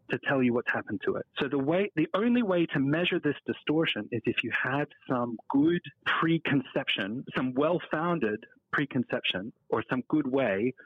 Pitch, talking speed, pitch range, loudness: 140 Hz, 170 wpm, 125-165 Hz, -29 LUFS